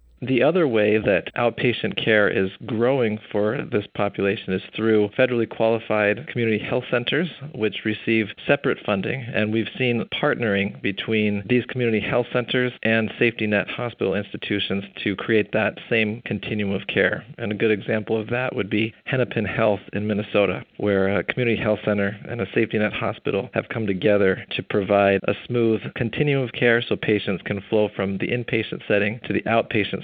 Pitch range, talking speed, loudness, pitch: 105-120 Hz, 170 wpm, -22 LUFS, 110 Hz